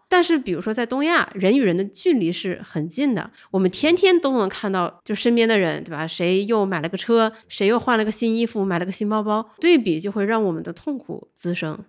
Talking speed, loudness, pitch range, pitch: 330 characters per minute, -21 LUFS, 185-235 Hz, 210 Hz